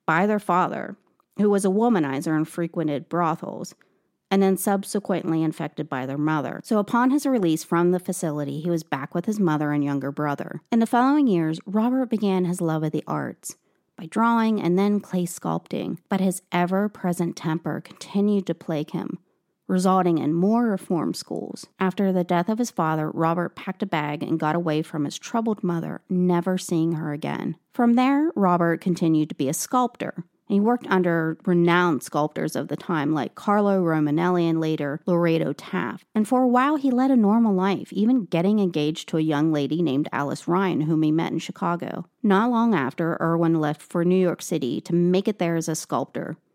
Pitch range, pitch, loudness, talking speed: 160-200 Hz, 175 Hz, -23 LUFS, 190 wpm